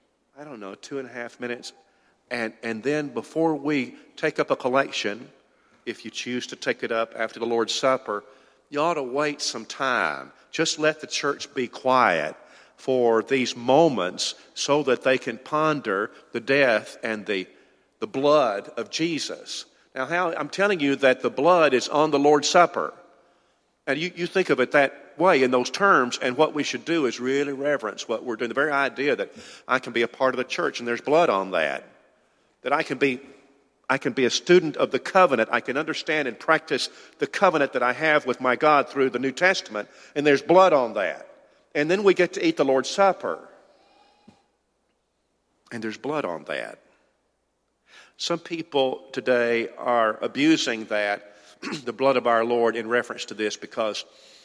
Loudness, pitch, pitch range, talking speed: -23 LUFS, 135 Hz, 120-150 Hz, 190 wpm